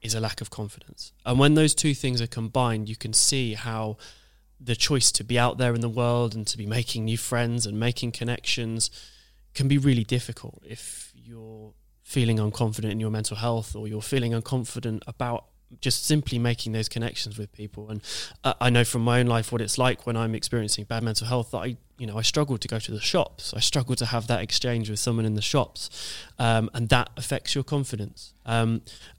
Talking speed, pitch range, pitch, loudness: 210 wpm, 110-125 Hz, 115 Hz, -25 LUFS